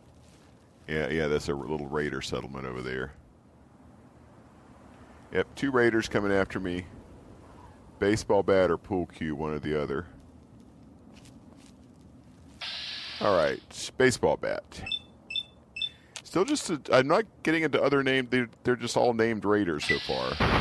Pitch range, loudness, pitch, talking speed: 75-120 Hz, -28 LUFS, 95 Hz, 130 wpm